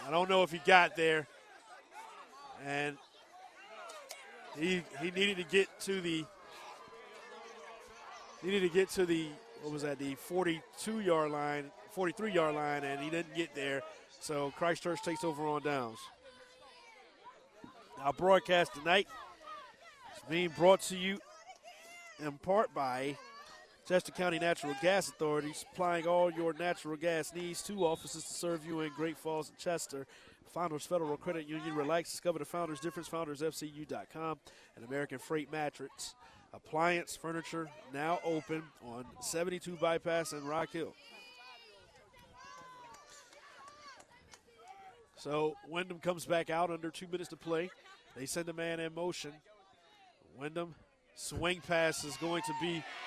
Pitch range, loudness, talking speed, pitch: 150-180 Hz, -35 LUFS, 135 wpm, 165 Hz